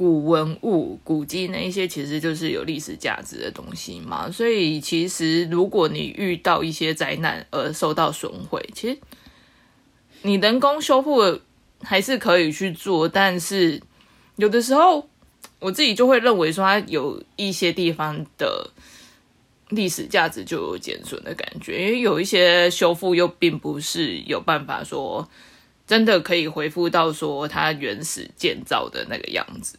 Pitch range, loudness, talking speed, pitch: 165-210 Hz, -21 LUFS, 235 characters per minute, 180 Hz